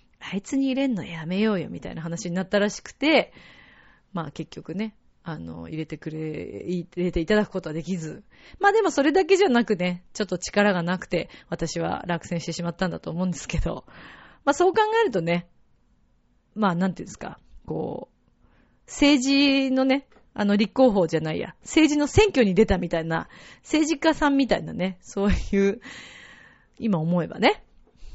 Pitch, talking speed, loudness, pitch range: 195 Hz, 340 characters per minute, -24 LUFS, 170-270 Hz